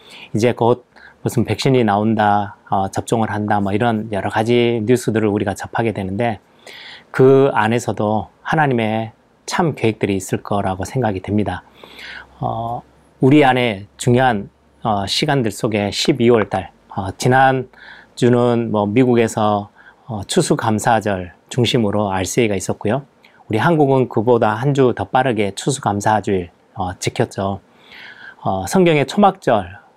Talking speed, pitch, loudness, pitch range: 275 characters per minute, 115 Hz, -17 LUFS, 105-125 Hz